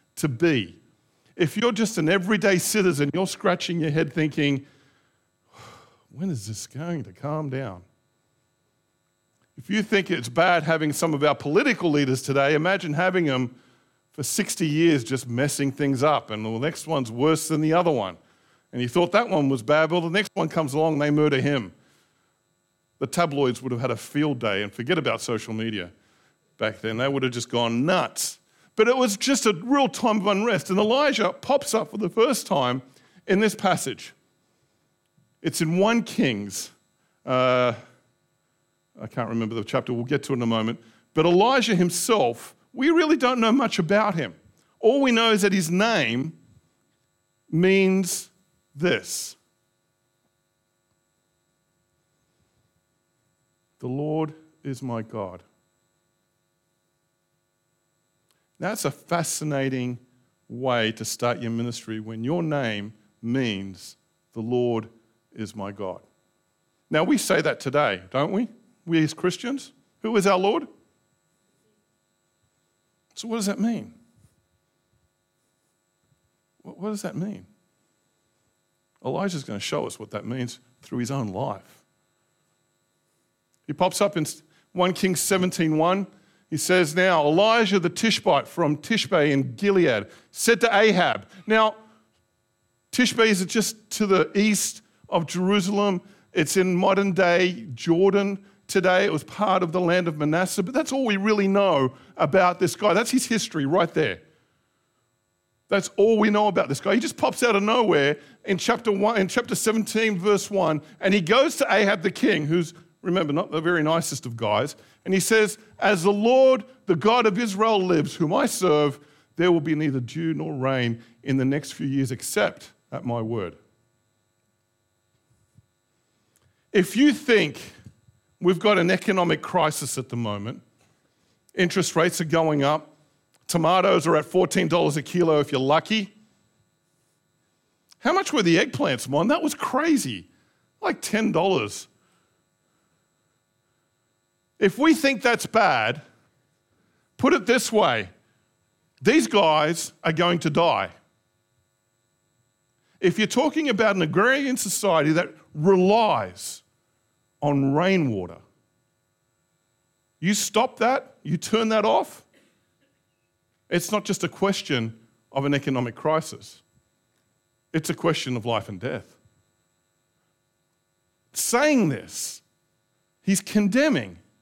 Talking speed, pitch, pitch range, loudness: 145 wpm, 170 Hz, 130-200 Hz, -23 LUFS